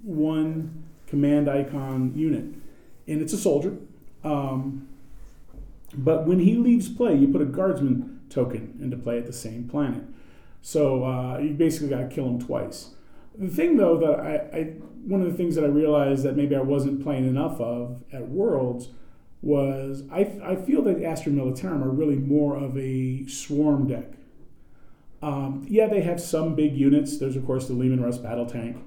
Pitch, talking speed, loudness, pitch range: 145 Hz, 175 wpm, -25 LUFS, 130-160 Hz